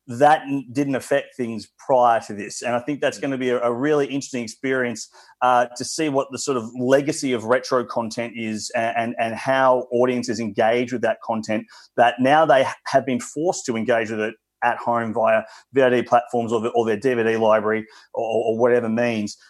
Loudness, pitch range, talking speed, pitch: -21 LUFS, 115-130 Hz, 200 wpm, 120 Hz